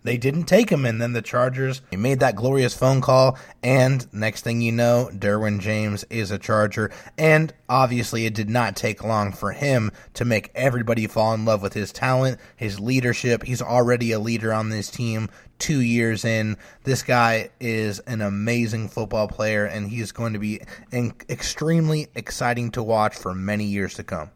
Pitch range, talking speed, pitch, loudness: 105-125 Hz, 185 wpm, 115 Hz, -22 LUFS